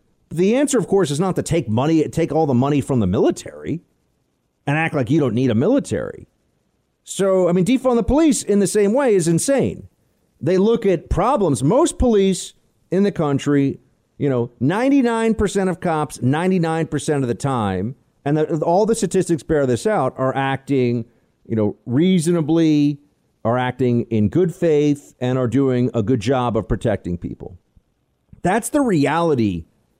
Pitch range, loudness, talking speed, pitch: 125-185 Hz, -19 LUFS, 170 wpm, 155 Hz